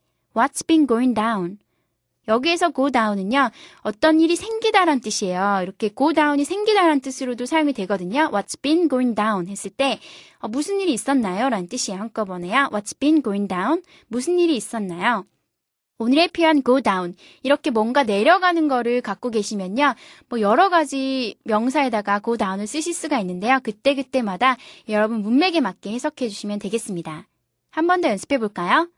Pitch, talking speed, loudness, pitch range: 255 Hz, 460 characters per minute, -21 LUFS, 210-315 Hz